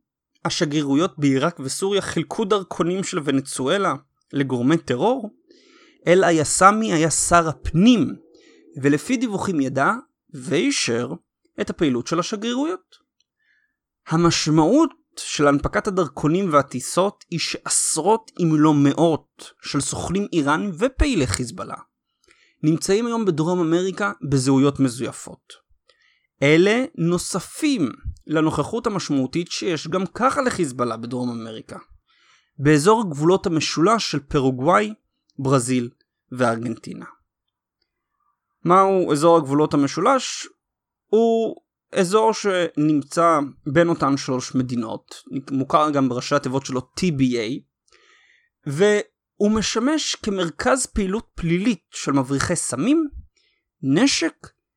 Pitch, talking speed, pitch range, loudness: 170 Hz, 95 wpm, 145-215 Hz, -20 LUFS